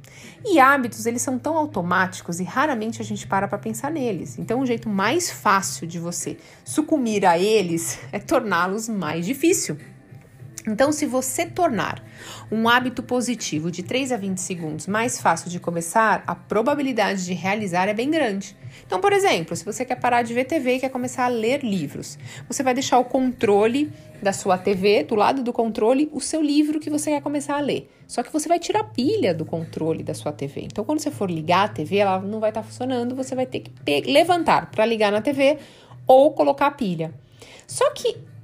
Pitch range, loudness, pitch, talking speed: 180-275 Hz, -22 LUFS, 230 Hz, 200 wpm